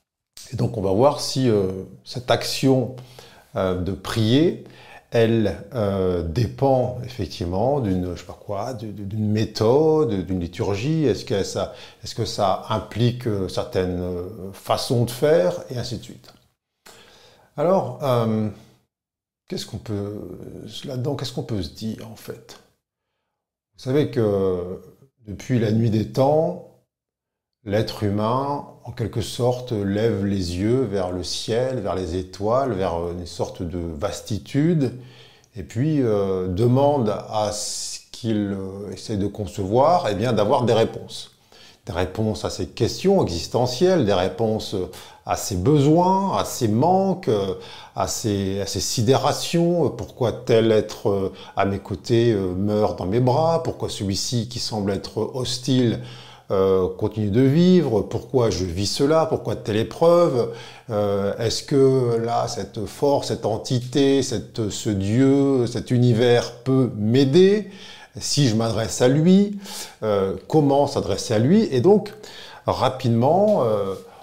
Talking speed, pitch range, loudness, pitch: 140 wpm, 100-130 Hz, -22 LUFS, 115 Hz